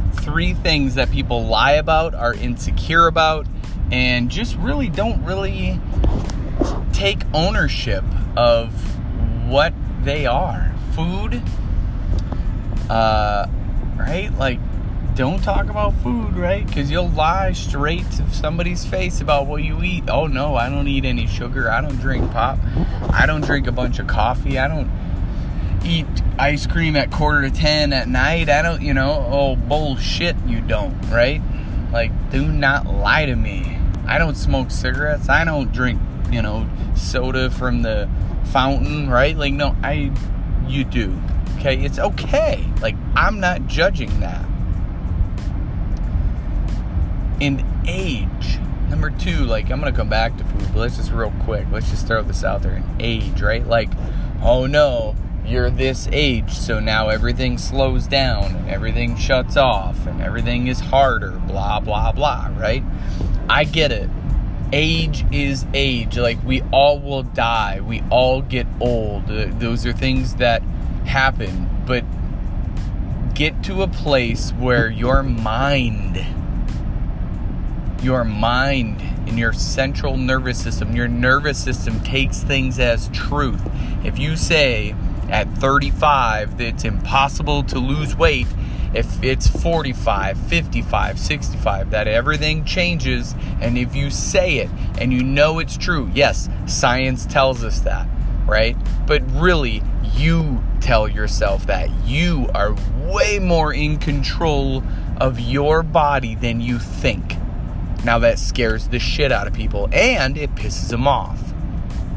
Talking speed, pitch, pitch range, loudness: 145 wpm, 115 Hz, 95-130 Hz, -19 LUFS